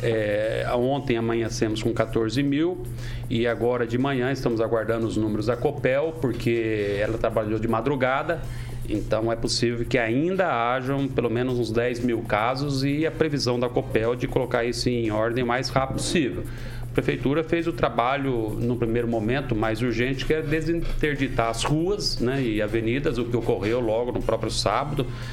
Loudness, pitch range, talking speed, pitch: -25 LUFS, 115-135 Hz, 170 wpm, 120 Hz